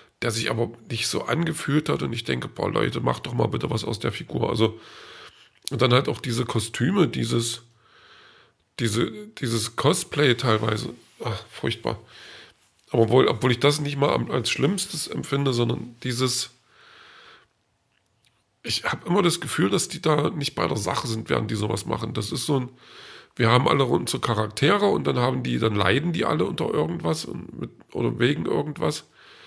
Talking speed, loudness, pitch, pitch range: 180 wpm, -24 LUFS, 120 Hz, 115-145 Hz